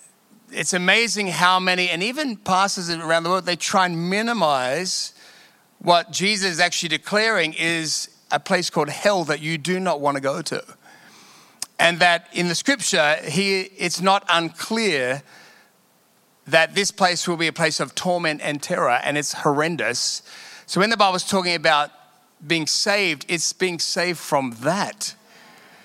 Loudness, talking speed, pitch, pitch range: -20 LUFS, 160 wpm, 175 Hz, 160-190 Hz